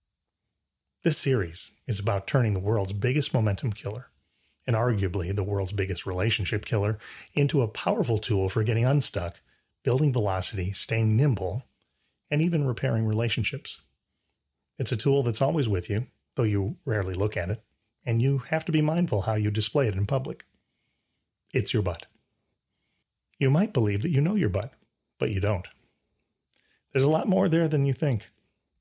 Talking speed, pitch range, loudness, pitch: 165 wpm, 100-135 Hz, -27 LUFS, 110 Hz